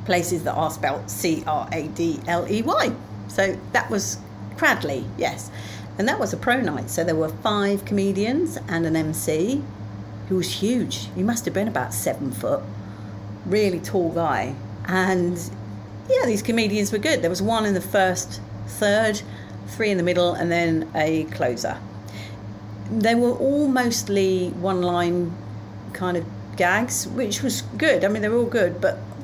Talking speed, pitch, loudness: 170 wpm, 170 Hz, -23 LUFS